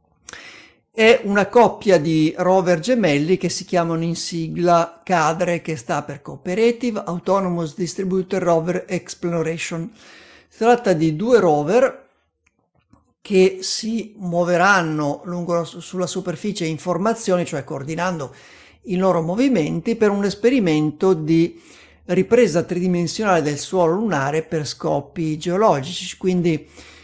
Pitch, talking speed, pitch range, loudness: 180 Hz, 115 wpm, 165-195 Hz, -19 LUFS